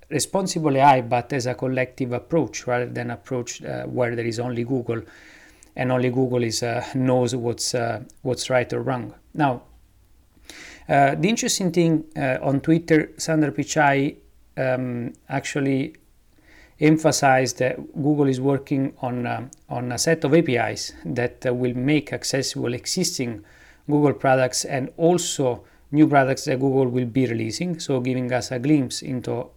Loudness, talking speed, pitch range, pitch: -22 LUFS, 150 wpm, 125-145 Hz, 130 Hz